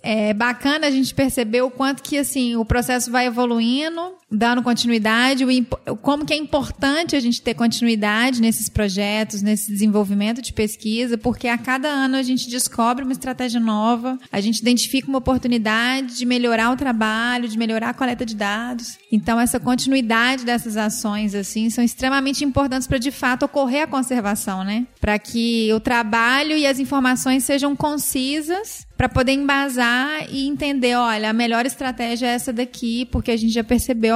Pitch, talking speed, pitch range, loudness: 245 Hz, 170 wpm, 230-265 Hz, -20 LUFS